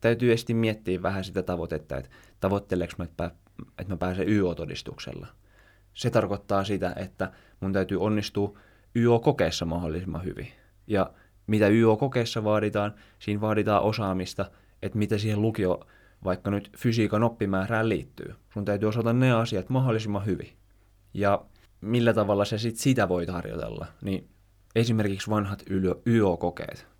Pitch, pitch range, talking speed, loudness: 100 Hz, 95-110 Hz, 130 wpm, -27 LUFS